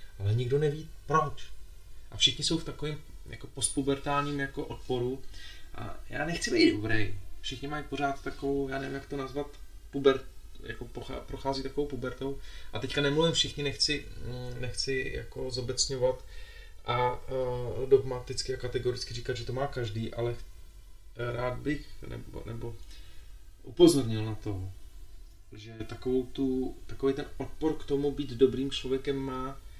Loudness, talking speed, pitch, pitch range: -31 LUFS, 140 wpm, 130 Hz, 115-140 Hz